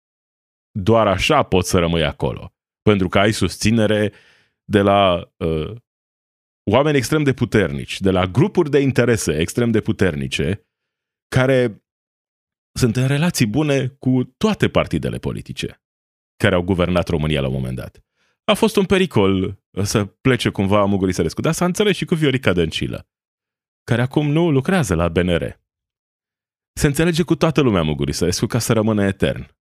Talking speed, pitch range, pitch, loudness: 150 wpm, 90-135 Hz, 110 Hz, -18 LUFS